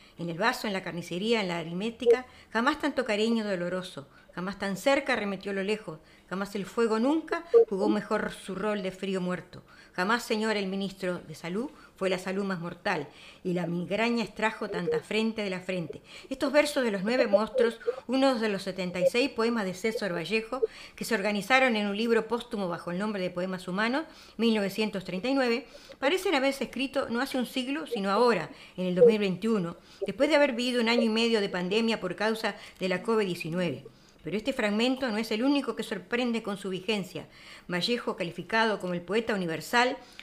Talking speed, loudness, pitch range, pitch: 185 wpm, -29 LUFS, 185-240 Hz, 215 Hz